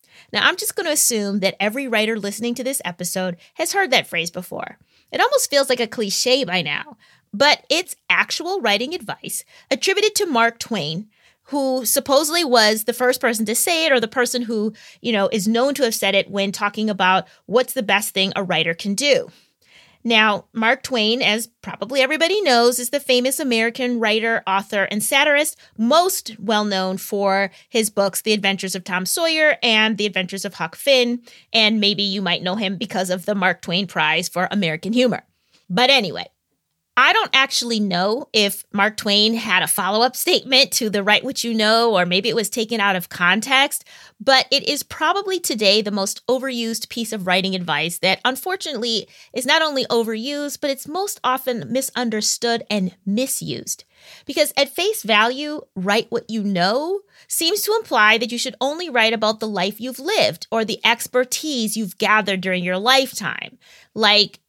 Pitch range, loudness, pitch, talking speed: 200-265 Hz, -19 LUFS, 225 Hz, 180 wpm